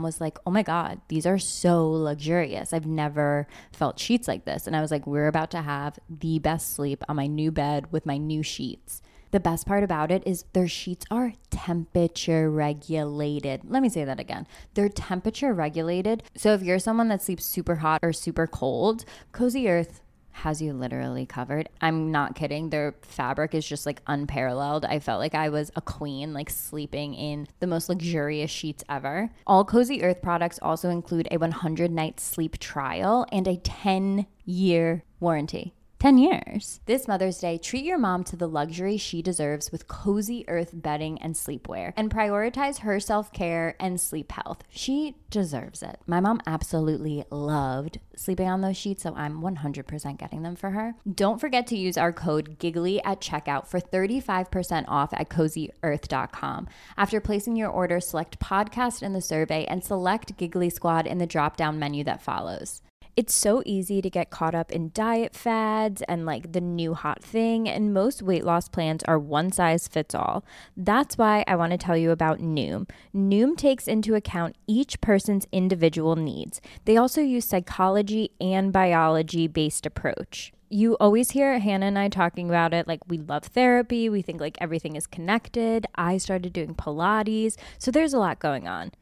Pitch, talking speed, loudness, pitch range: 175 Hz, 180 wpm, -26 LUFS, 155-205 Hz